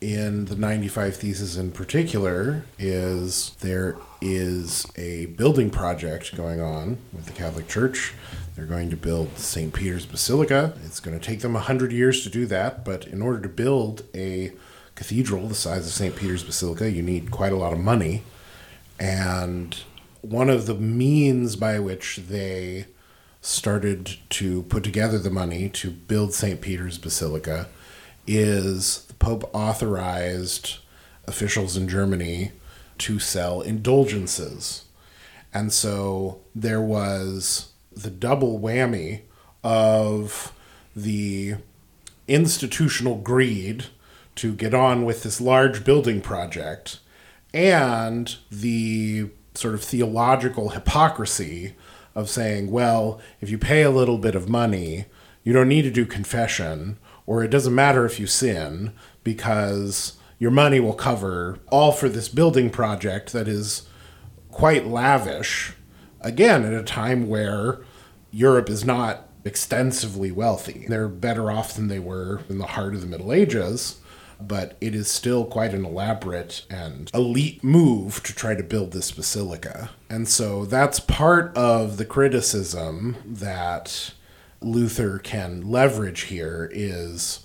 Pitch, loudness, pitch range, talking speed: 105 Hz, -23 LUFS, 95-115 Hz, 135 wpm